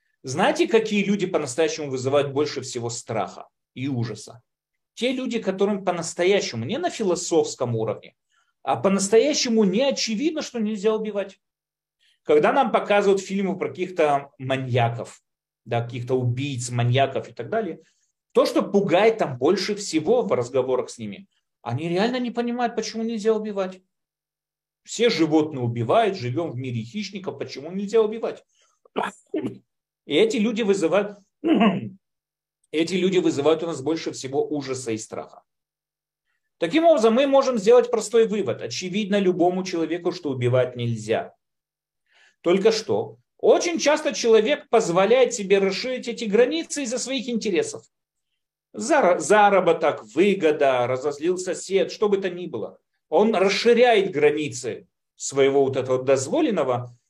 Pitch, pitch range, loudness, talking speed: 195 Hz, 145-230 Hz, -22 LUFS, 130 wpm